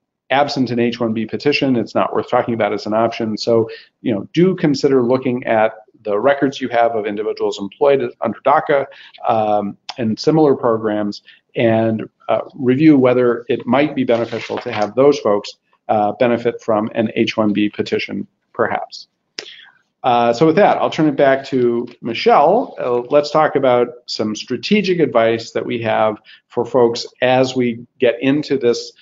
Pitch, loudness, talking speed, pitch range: 120 Hz, -17 LUFS, 165 wpm, 110-135 Hz